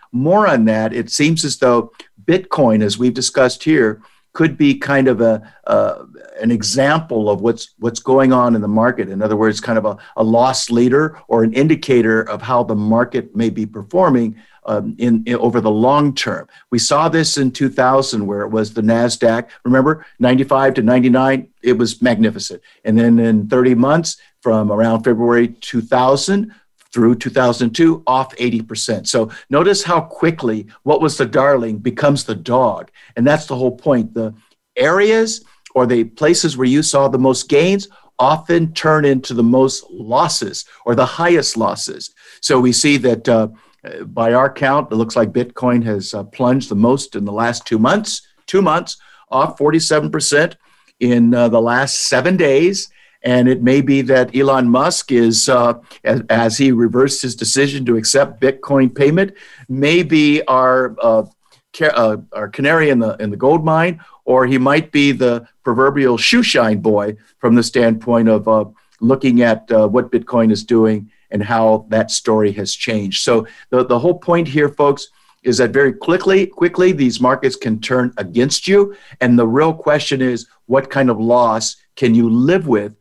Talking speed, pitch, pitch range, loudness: 175 wpm, 125 Hz, 115-140 Hz, -15 LUFS